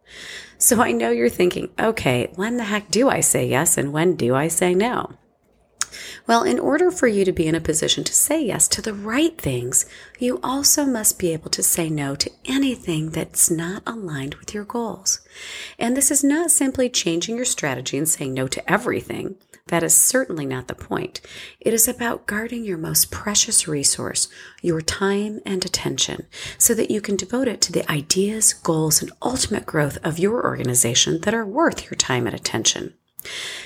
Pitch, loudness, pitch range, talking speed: 185 Hz, -20 LUFS, 155-235 Hz, 190 wpm